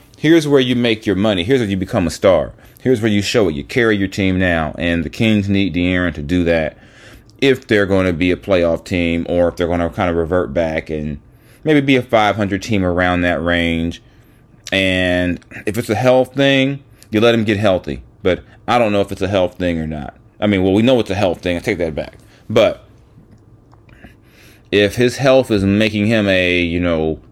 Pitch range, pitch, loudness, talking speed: 90-115 Hz, 100 Hz, -16 LUFS, 220 wpm